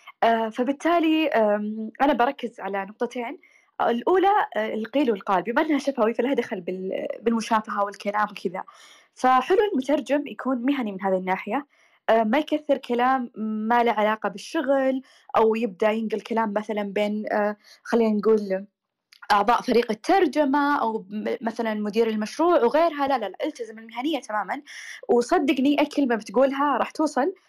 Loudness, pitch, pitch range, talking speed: -24 LUFS, 235 Hz, 215-285 Hz, 120 wpm